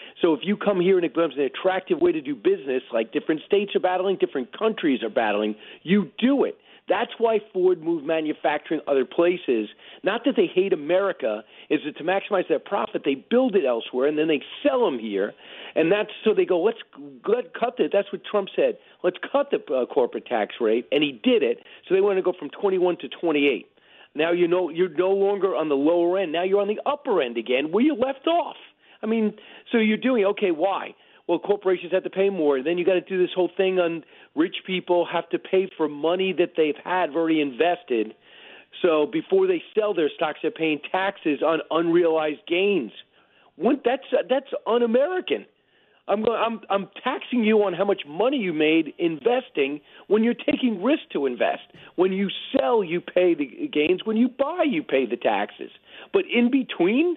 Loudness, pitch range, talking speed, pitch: -23 LUFS, 170-260 Hz, 200 wpm, 195 Hz